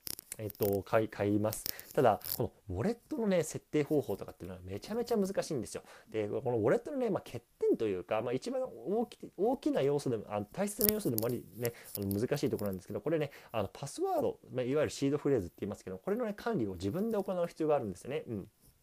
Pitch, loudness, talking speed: 150 Hz, -35 LUFS, 500 characters per minute